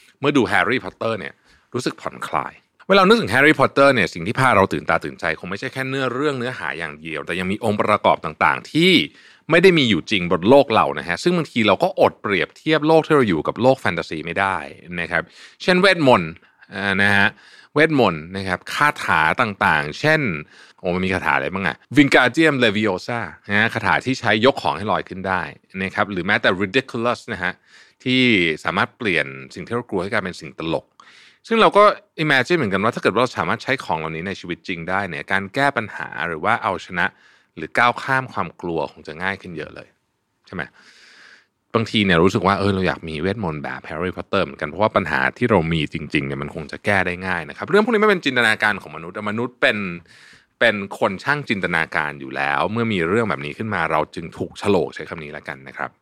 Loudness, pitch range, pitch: -19 LUFS, 85-130 Hz, 100 Hz